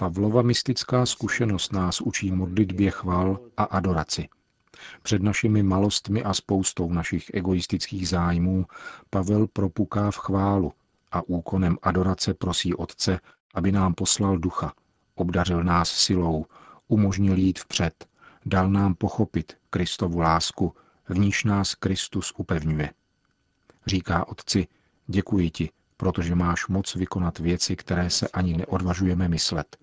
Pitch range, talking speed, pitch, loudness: 90-100 Hz, 120 wpm, 95 Hz, -25 LUFS